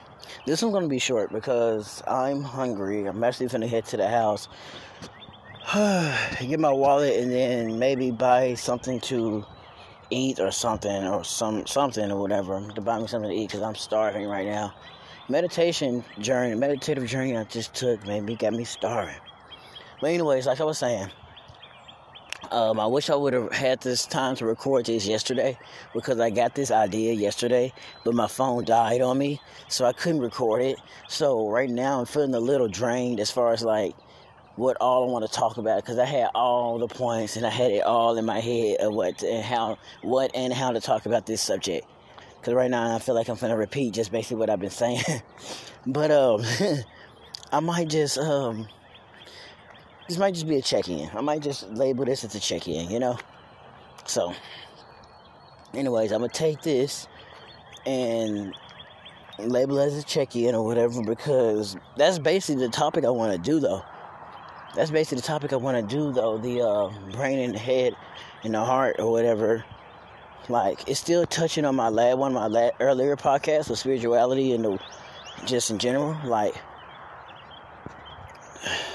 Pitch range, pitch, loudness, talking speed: 110-135 Hz, 120 Hz, -25 LUFS, 185 wpm